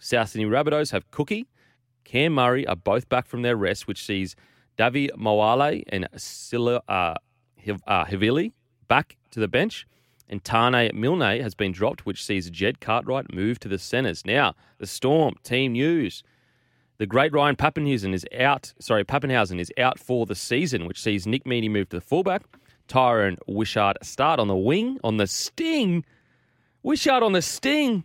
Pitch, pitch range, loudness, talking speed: 120 Hz, 105-145 Hz, -24 LUFS, 170 wpm